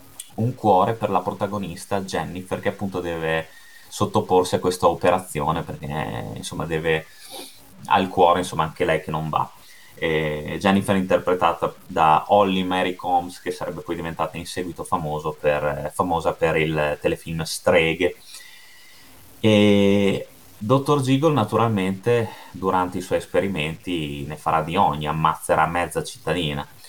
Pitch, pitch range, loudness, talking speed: 90 Hz, 80-100 Hz, -22 LUFS, 130 wpm